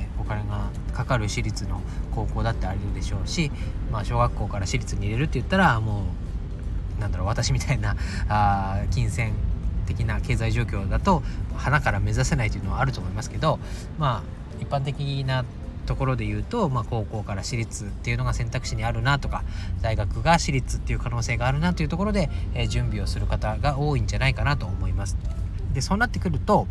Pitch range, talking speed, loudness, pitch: 95-125 Hz, 390 characters per minute, -26 LUFS, 105 Hz